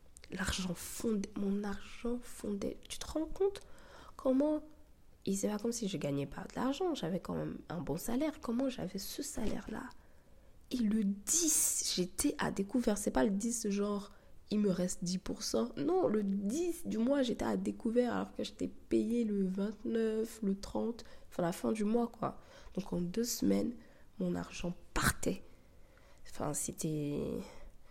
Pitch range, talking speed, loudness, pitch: 185-240 Hz, 165 wpm, -36 LUFS, 210 Hz